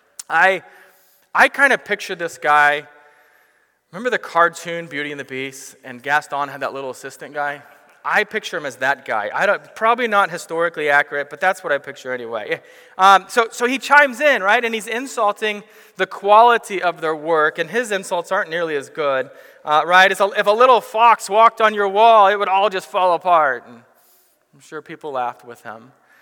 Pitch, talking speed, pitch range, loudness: 185 Hz, 195 wpm, 145-215 Hz, -17 LUFS